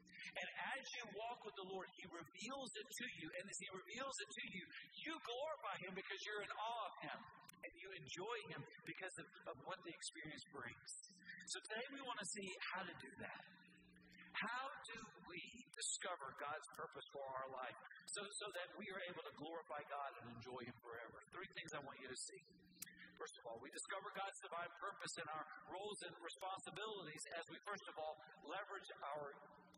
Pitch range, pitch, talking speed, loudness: 160-210 Hz, 190 Hz, 200 wpm, -51 LUFS